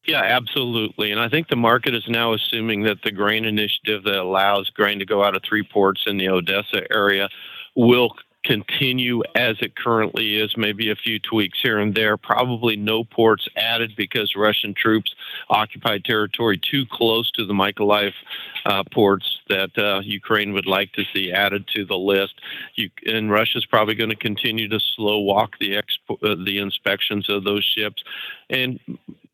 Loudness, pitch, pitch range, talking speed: -20 LUFS, 105 Hz, 100-115 Hz, 180 wpm